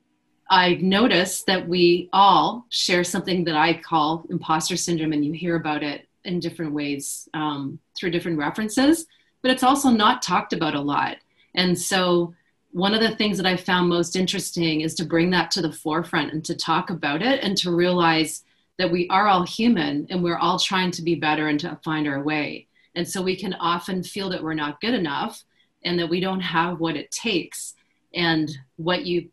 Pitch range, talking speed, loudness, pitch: 160-185 Hz, 200 wpm, -22 LUFS, 175 Hz